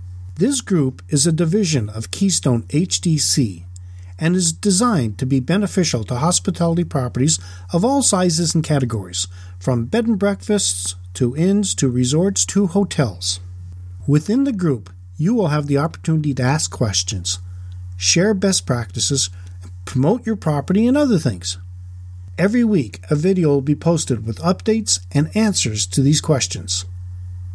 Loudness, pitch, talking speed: -18 LUFS, 140 Hz, 145 wpm